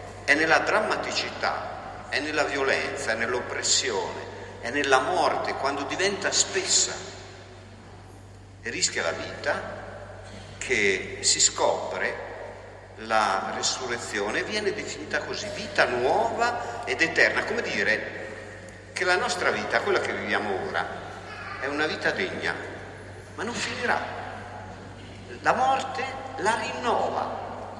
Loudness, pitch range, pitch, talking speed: -25 LUFS, 95-110 Hz, 100 Hz, 110 wpm